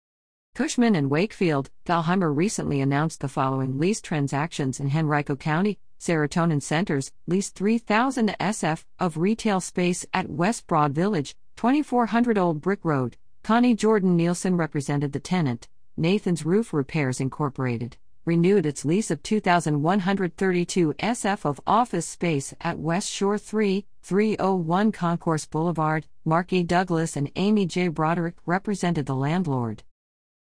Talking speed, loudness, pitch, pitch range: 130 wpm, -24 LUFS, 170 Hz, 150-195 Hz